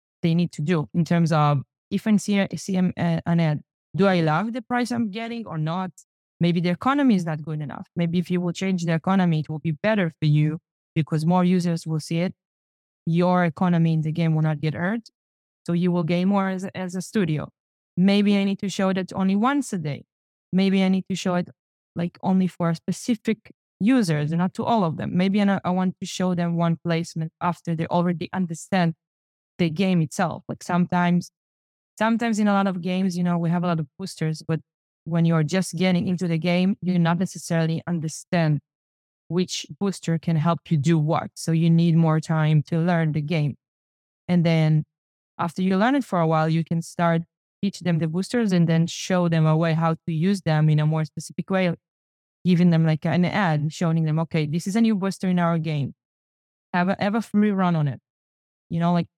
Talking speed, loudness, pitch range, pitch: 215 wpm, -23 LUFS, 160-190 Hz, 170 Hz